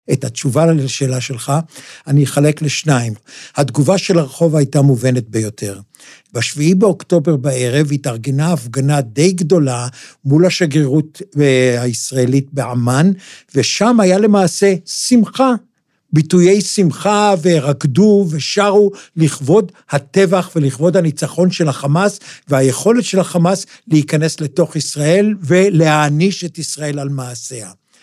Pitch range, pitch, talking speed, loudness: 140-185 Hz, 155 Hz, 105 wpm, -14 LUFS